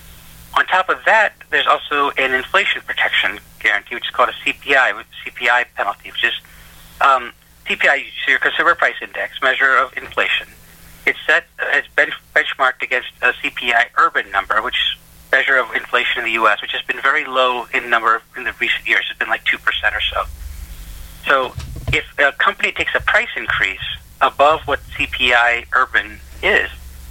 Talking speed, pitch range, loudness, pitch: 170 wpm, 80-135 Hz, -16 LUFS, 120 Hz